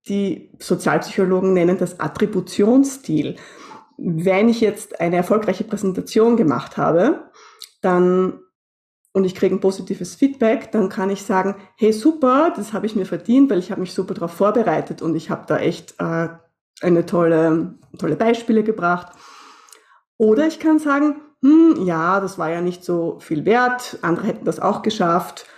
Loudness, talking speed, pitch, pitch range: -19 LUFS, 155 wpm, 195 Hz, 175-225 Hz